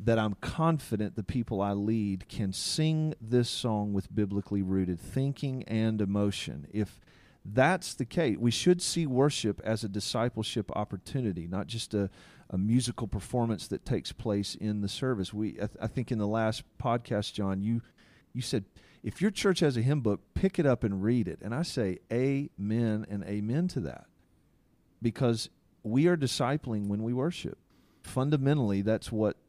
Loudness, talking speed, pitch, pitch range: -31 LUFS, 175 wpm, 110 Hz, 100-130 Hz